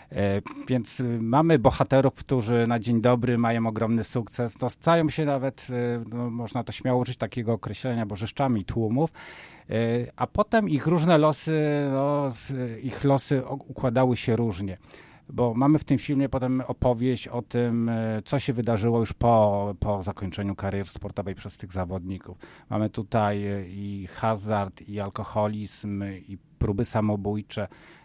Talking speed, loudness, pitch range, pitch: 135 wpm, -26 LUFS, 105-130 Hz, 115 Hz